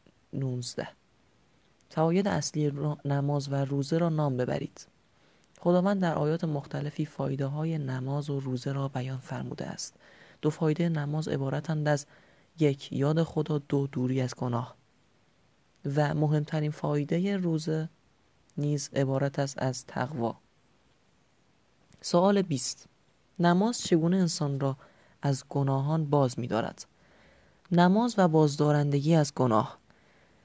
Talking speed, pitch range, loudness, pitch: 115 wpm, 140-160 Hz, -29 LUFS, 150 Hz